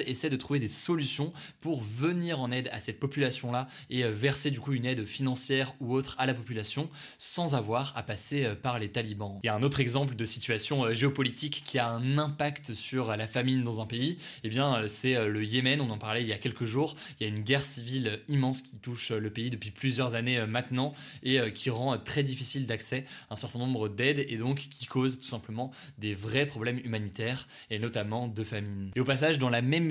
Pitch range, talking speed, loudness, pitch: 115-140 Hz, 220 wpm, -31 LUFS, 130 Hz